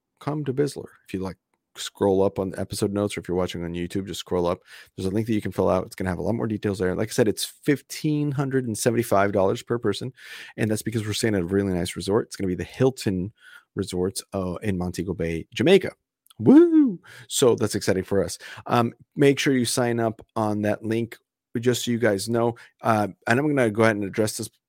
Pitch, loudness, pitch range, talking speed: 105 Hz, -24 LUFS, 95-120 Hz, 245 wpm